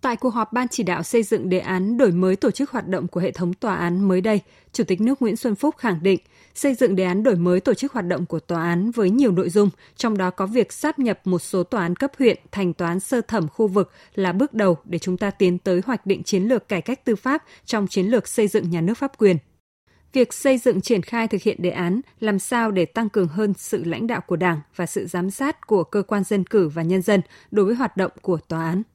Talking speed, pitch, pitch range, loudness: 270 wpm, 200 Hz, 180-235 Hz, -22 LUFS